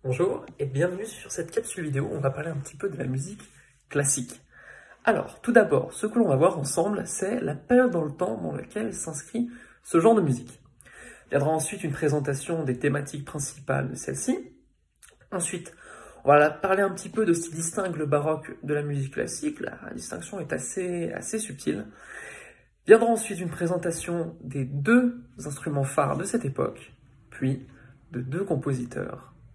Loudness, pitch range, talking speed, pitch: -26 LUFS, 140-195 Hz, 175 wpm, 160 Hz